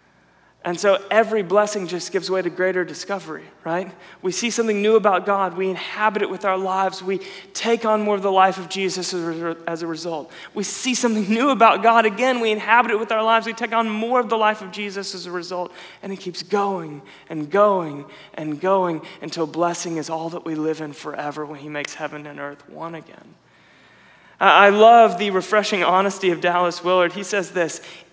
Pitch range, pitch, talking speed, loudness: 170-210 Hz, 190 Hz, 205 wpm, -20 LUFS